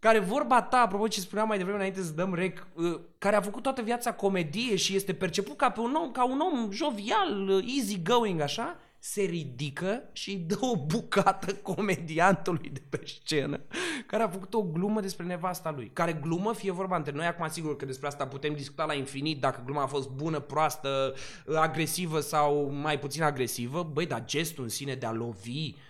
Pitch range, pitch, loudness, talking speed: 150-205 Hz, 175 Hz, -30 LUFS, 195 wpm